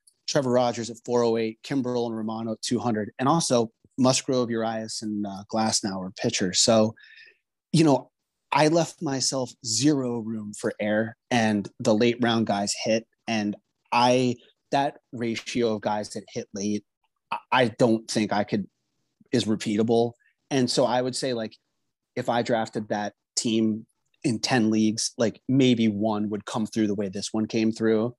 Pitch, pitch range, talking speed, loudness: 115 Hz, 110-125 Hz, 165 wpm, -25 LUFS